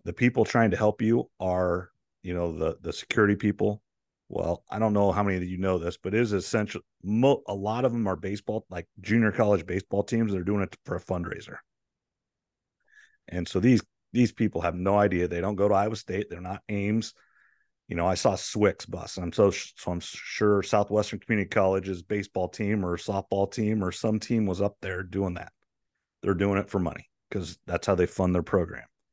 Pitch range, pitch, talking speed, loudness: 90-105 Hz, 100 Hz, 210 wpm, -27 LUFS